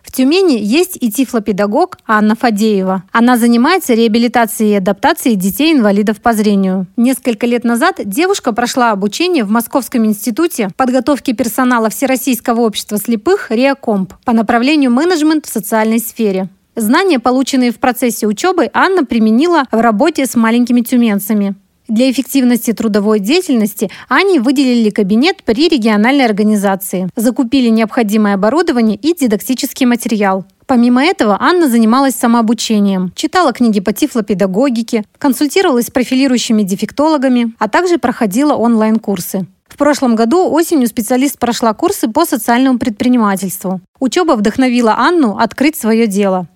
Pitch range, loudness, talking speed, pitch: 220-275 Hz, -12 LUFS, 125 wpm, 240 Hz